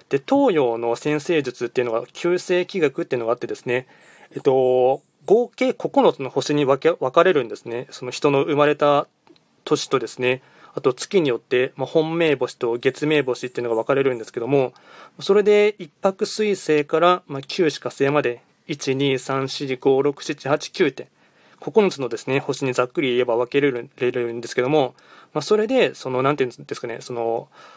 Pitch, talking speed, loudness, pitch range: 140 Hz, 335 characters per minute, -21 LUFS, 125-160 Hz